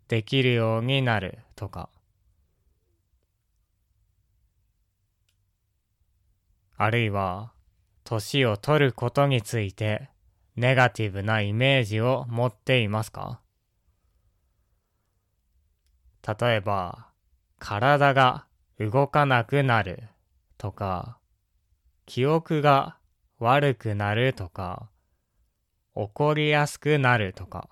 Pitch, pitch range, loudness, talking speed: 105 Hz, 90-125 Hz, -24 LUFS, 160 characters per minute